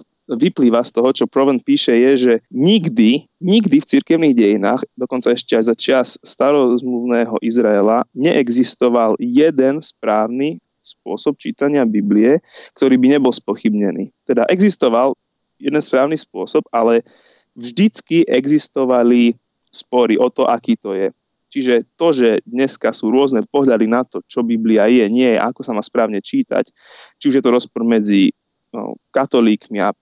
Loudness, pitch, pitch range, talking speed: -15 LUFS, 130 Hz, 120-150 Hz, 140 wpm